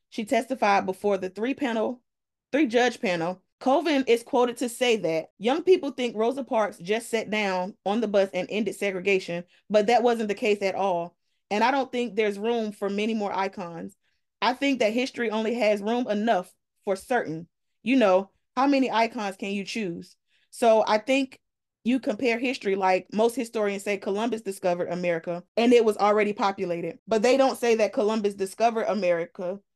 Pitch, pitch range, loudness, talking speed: 215 Hz, 195-240 Hz, -25 LUFS, 180 wpm